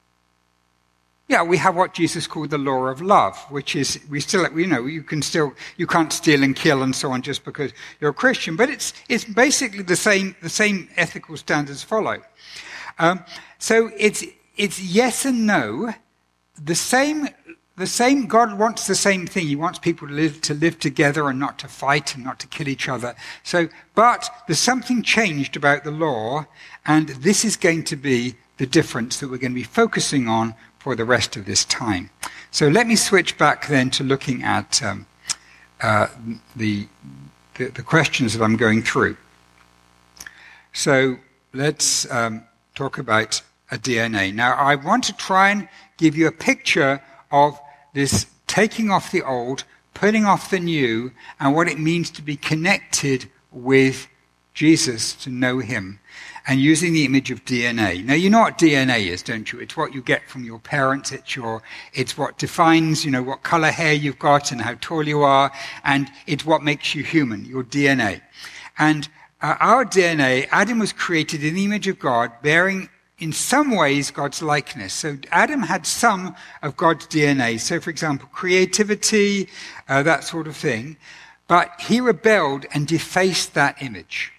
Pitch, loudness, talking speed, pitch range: 150 Hz, -20 LUFS, 180 wpm, 130-180 Hz